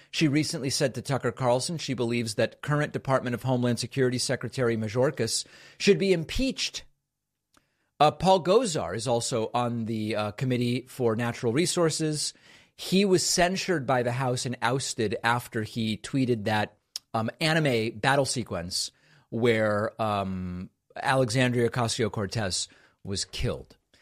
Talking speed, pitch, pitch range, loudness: 135 wpm, 125 Hz, 115-140 Hz, -27 LUFS